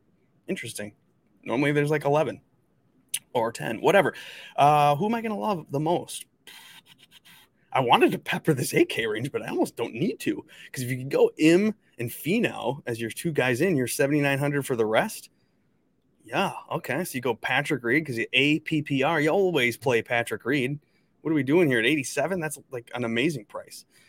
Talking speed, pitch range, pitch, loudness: 185 wpm, 125-175 Hz, 145 Hz, -25 LUFS